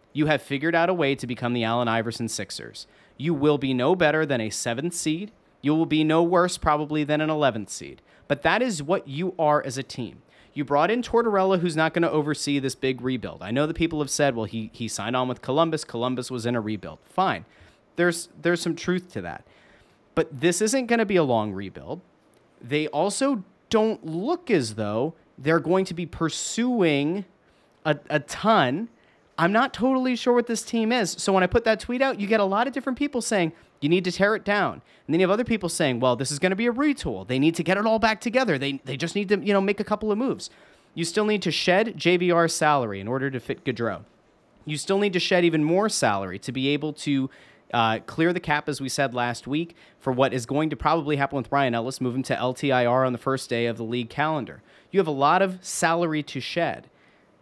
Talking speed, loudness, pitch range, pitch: 235 wpm, -24 LUFS, 130-190 Hz, 155 Hz